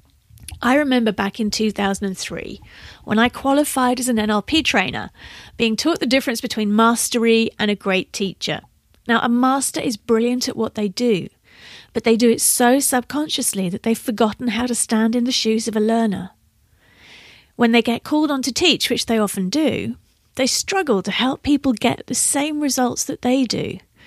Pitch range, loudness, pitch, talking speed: 215-260 Hz, -19 LUFS, 235 Hz, 180 wpm